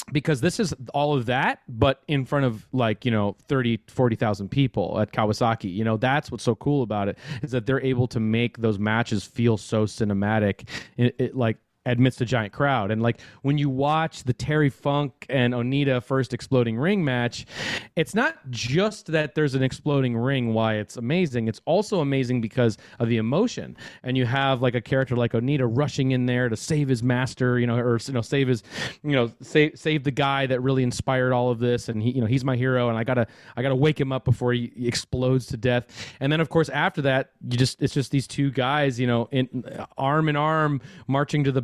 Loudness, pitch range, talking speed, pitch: -24 LUFS, 120-140 Hz, 220 wpm, 130 Hz